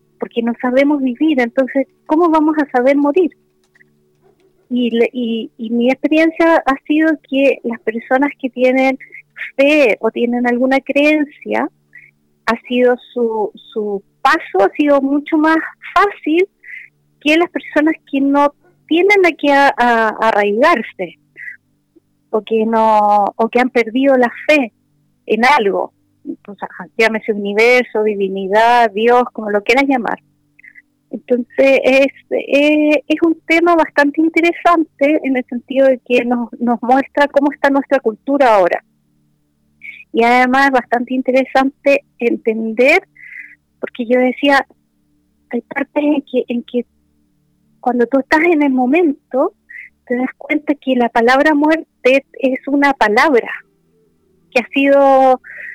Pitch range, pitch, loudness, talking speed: 235-295 Hz, 260 Hz, -14 LUFS, 130 wpm